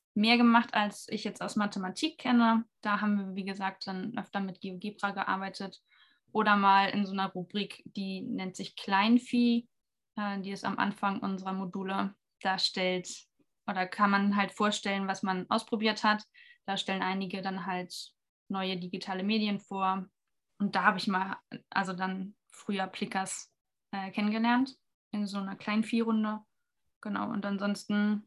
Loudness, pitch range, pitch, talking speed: -31 LUFS, 195-215 Hz, 200 Hz, 150 wpm